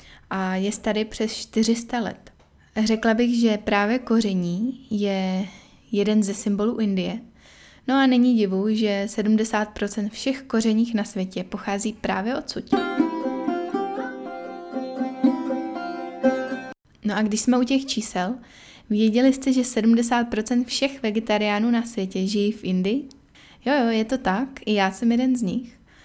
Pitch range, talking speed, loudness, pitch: 205-250 Hz, 135 wpm, -23 LUFS, 220 Hz